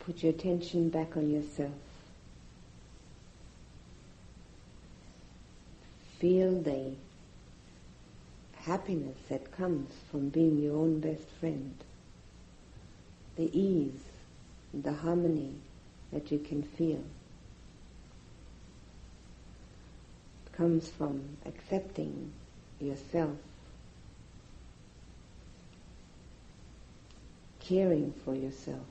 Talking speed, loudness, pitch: 70 wpm, -34 LUFS, 145 Hz